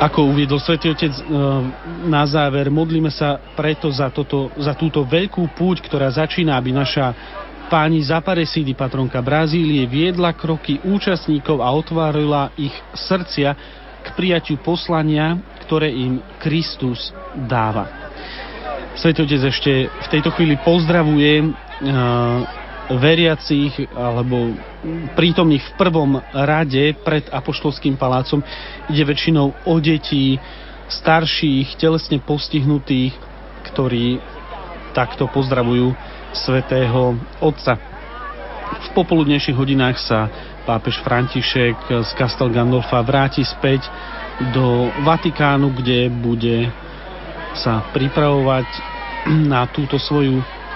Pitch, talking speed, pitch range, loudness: 145 Hz, 100 wpm, 130-160 Hz, -18 LUFS